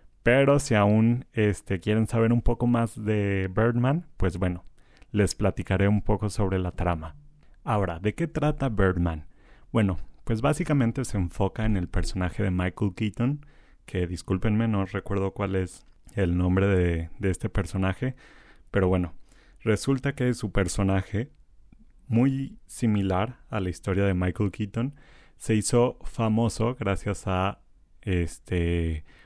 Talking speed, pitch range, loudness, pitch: 140 wpm, 95-115 Hz, -26 LUFS, 100 Hz